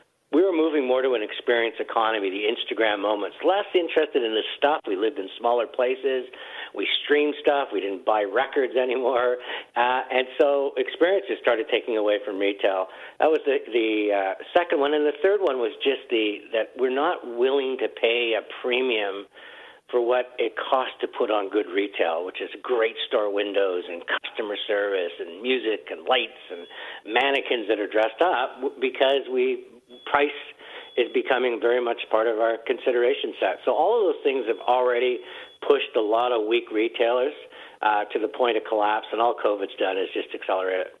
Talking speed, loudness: 185 wpm, -24 LUFS